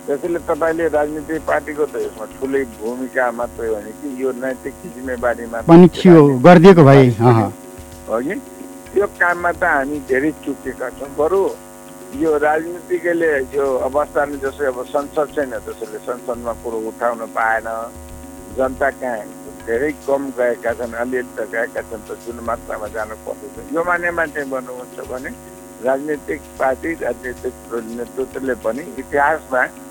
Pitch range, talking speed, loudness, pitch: 120-155 Hz, 110 wpm, -17 LUFS, 130 Hz